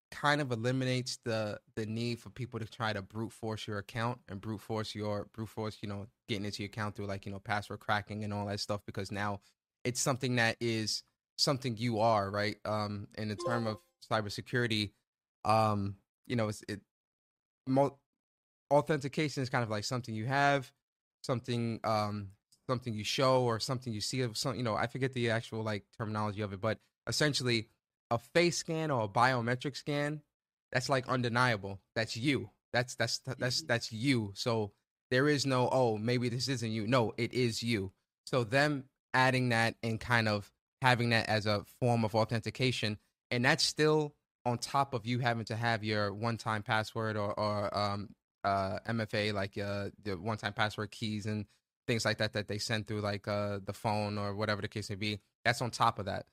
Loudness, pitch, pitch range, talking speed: -33 LUFS, 115 Hz, 105-125 Hz, 195 wpm